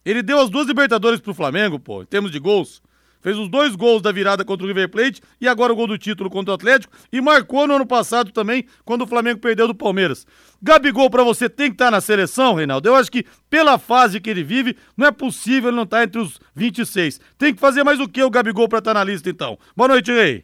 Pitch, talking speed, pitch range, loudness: 235 Hz, 260 wpm, 205-260 Hz, -17 LUFS